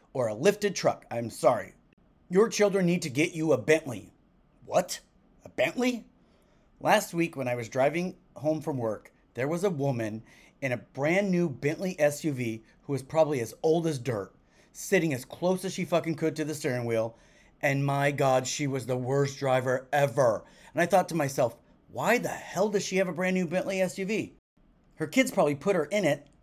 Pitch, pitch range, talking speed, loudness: 155 Hz, 140-185 Hz, 195 wpm, -28 LUFS